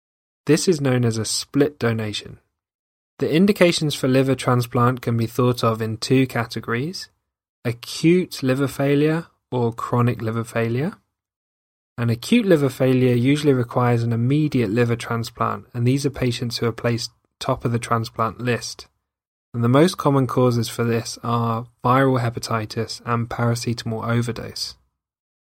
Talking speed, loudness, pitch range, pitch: 145 wpm, -21 LUFS, 115-135 Hz, 120 Hz